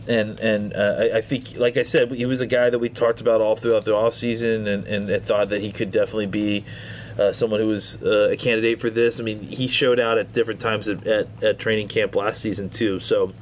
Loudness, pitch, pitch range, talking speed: -22 LUFS, 115 Hz, 105-130 Hz, 250 wpm